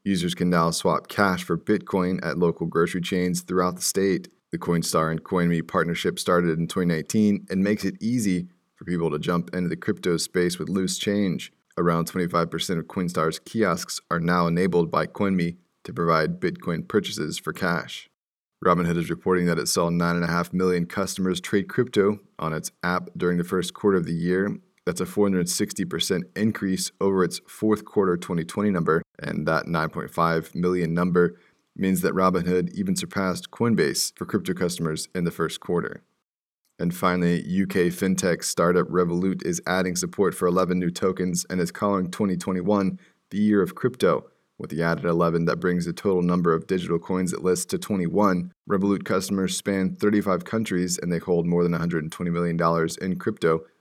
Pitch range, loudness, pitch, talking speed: 85-95 Hz, -24 LUFS, 90 Hz, 170 wpm